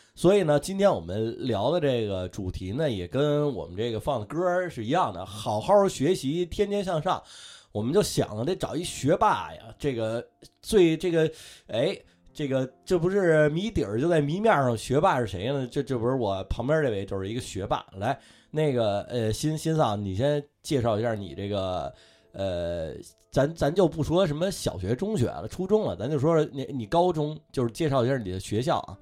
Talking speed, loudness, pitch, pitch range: 280 characters per minute, -27 LUFS, 140 Hz, 110-160 Hz